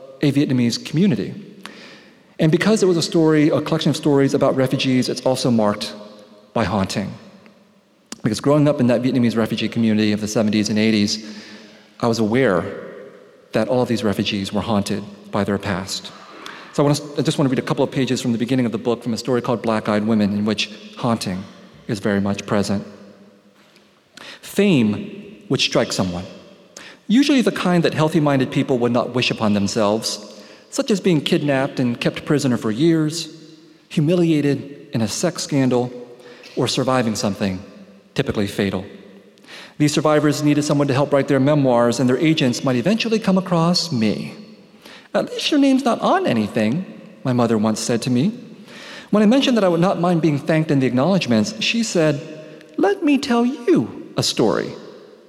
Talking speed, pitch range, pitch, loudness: 180 wpm, 110-160 Hz, 130 Hz, -19 LUFS